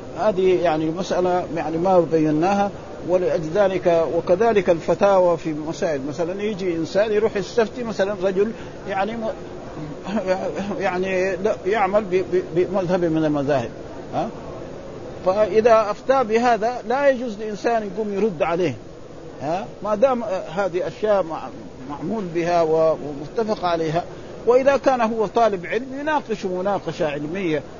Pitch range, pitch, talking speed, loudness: 170-215 Hz, 190 Hz, 110 wpm, -21 LUFS